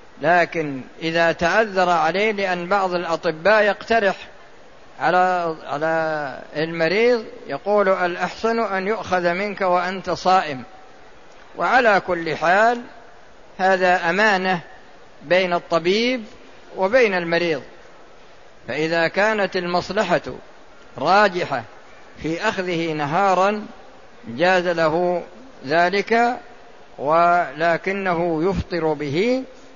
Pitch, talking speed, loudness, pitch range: 180 Hz, 80 wpm, -20 LUFS, 165-205 Hz